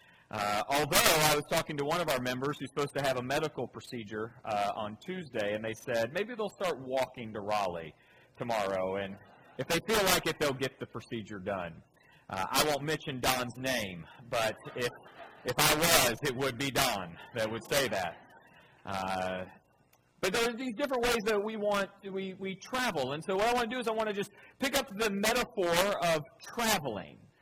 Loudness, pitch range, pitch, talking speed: -31 LUFS, 120-200 Hz, 150 Hz, 200 wpm